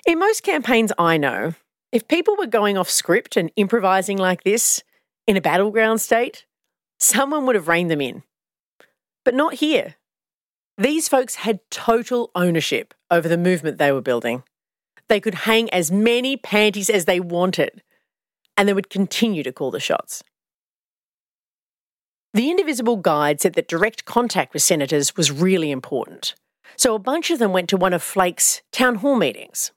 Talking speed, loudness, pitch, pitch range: 165 wpm, -19 LUFS, 205 Hz, 175-240 Hz